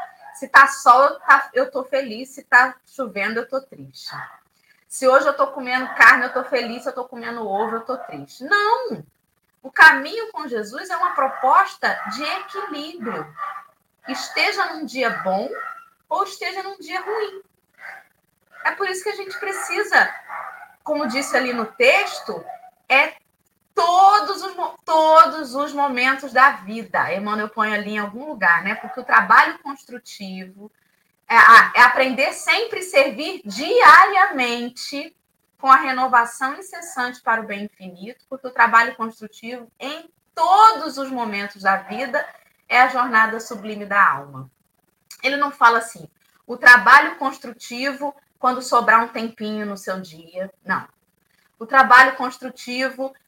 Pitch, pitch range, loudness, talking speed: 265 Hz, 230-315 Hz, -17 LUFS, 145 wpm